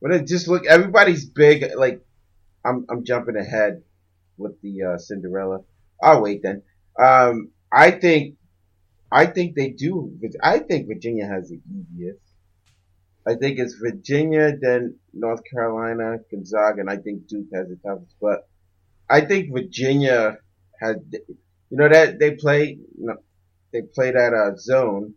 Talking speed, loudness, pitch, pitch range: 155 wpm, -19 LUFS, 115 Hz, 95-135 Hz